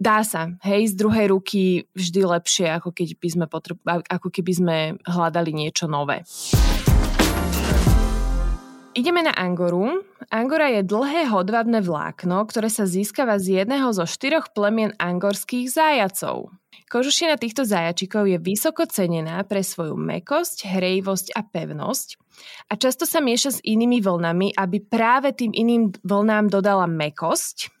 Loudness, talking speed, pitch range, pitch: -21 LUFS, 135 wpm, 175-230 Hz, 195 Hz